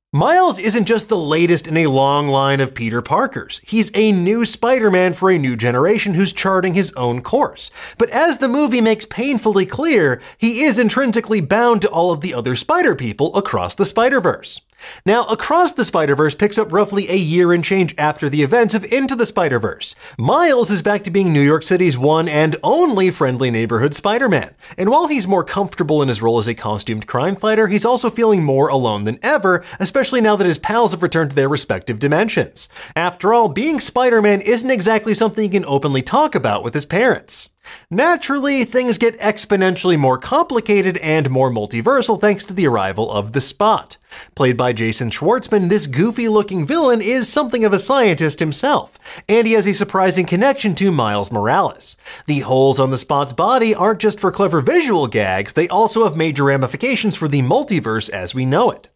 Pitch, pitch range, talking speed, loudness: 195 Hz, 145-225 Hz, 190 wpm, -16 LUFS